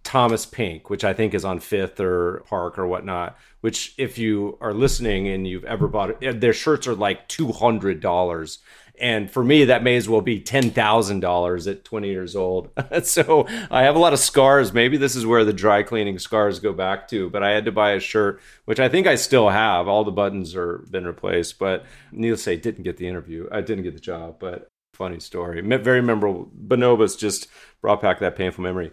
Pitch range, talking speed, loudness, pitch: 90-120 Hz, 205 wpm, -21 LUFS, 105 Hz